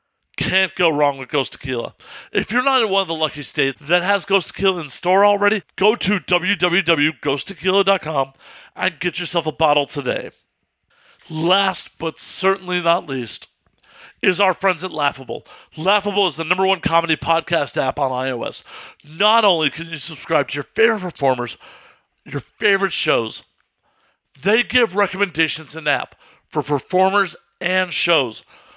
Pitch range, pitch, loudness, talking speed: 150-195 Hz, 175 Hz, -19 LUFS, 150 wpm